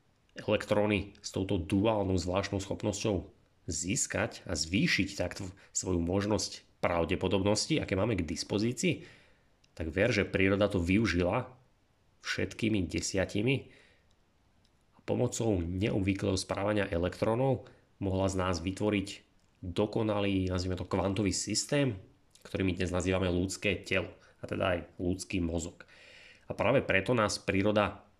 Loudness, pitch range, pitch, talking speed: -31 LUFS, 90-105 Hz, 100 Hz, 115 wpm